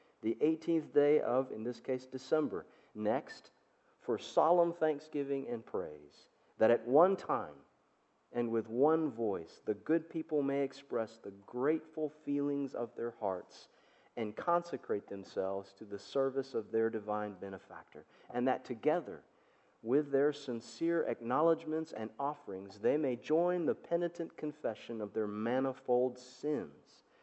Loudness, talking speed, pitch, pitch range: -35 LUFS, 135 wpm, 130 Hz, 115-155 Hz